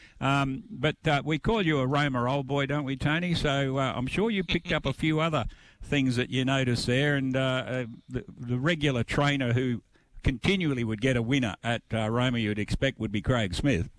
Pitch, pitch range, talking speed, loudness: 135 Hz, 120-145 Hz, 215 wpm, -28 LUFS